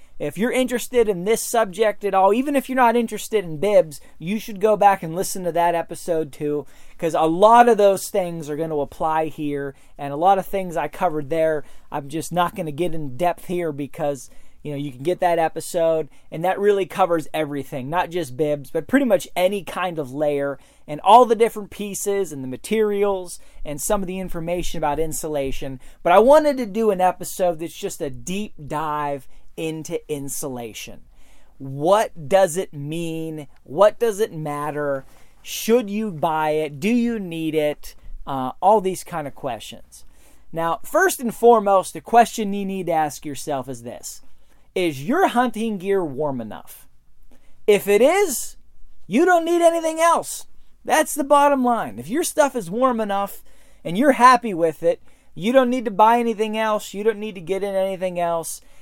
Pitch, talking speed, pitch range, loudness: 180 Hz, 190 wpm, 150-215 Hz, -21 LUFS